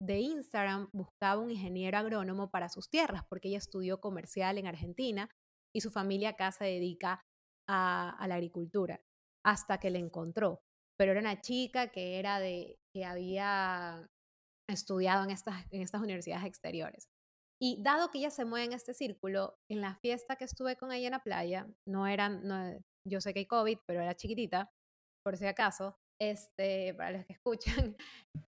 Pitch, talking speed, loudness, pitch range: 195 Hz, 175 wpm, -36 LUFS, 185-215 Hz